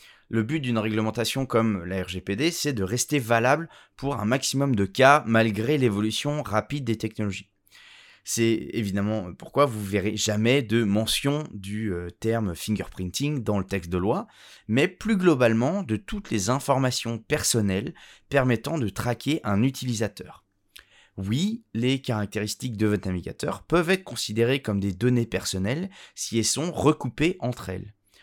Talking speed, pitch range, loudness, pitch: 150 wpm, 105-135 Hz, -25 LUFS, 115 Hz